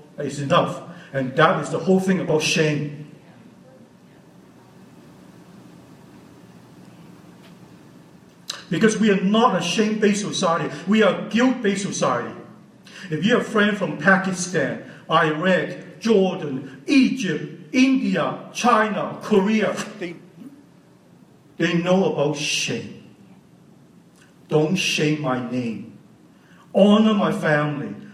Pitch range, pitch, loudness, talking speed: 155-205 Hz, 180 Hz, -20 LUFS, 100 wpm